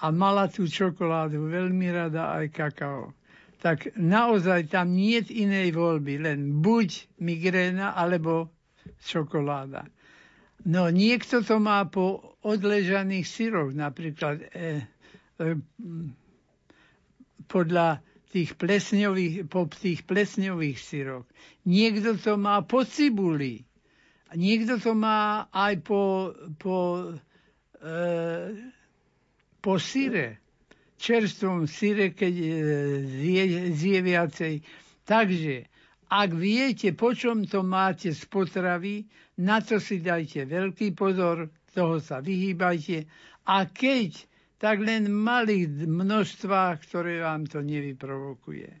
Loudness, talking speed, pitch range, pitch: -26 LUFS, 105 wpm, 160-205 Hz, 180 Hz